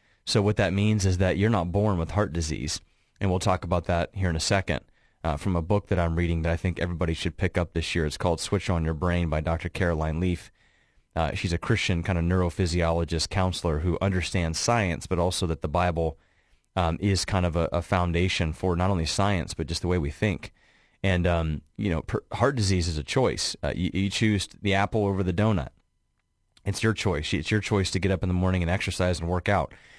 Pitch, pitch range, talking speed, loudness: 90 Hz, 85-100 Hz, 230 wpm, -26 LUFS